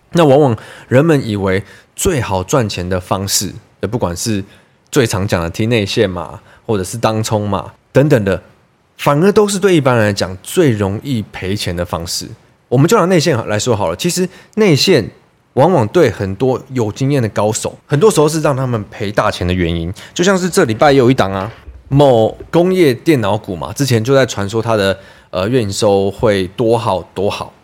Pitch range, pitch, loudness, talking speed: 95-140 Hz, 110 Hz, -14 LUFS, 270 characters per minute